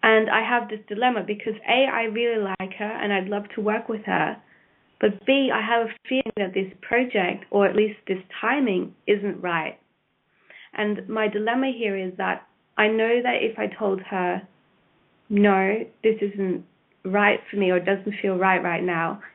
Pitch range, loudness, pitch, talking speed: 195-225 Hz, -24 LUFS, 210 Hz, 185 wpm